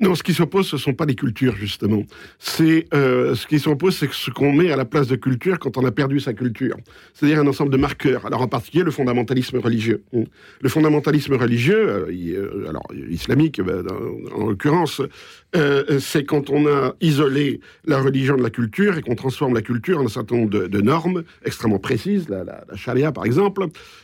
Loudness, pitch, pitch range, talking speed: -20 LUFS, 140 Hz, 120-150 Hz, 195 wpm